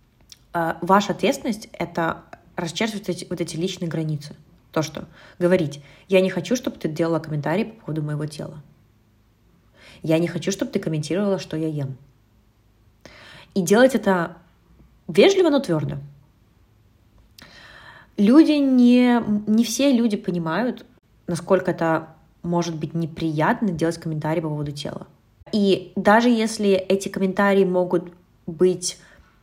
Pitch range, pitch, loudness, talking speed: 155-200 Hz, 175 Hz, -21 LUFS, 120 wpm